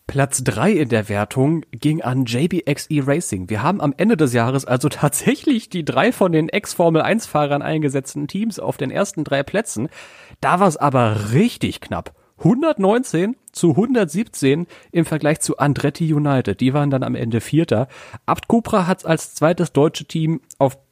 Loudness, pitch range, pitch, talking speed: -19 LUFS, 135-180 Hz, 155 Hz, 165 wpm